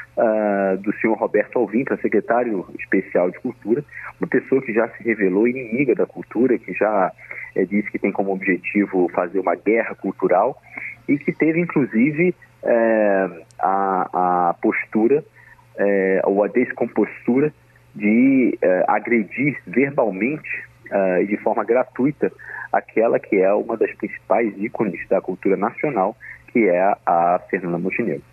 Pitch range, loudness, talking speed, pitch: 95-145 Hz, -20 LUFS, 145 wpm, 105 Hz